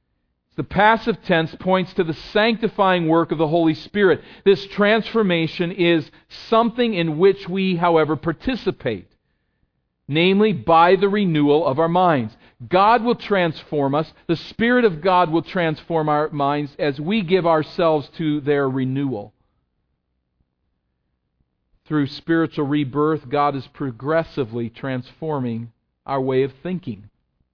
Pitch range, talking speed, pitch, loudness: 135-185 Hz, 125 wpm, 160 Hz, -20 LUFS